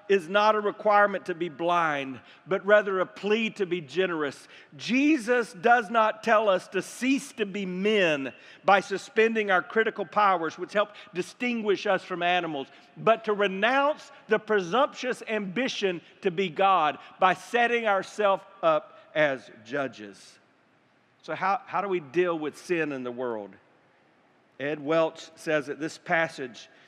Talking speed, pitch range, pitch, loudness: 150 wpm, 170-215 Hz, 195 Hz, -26 LUFS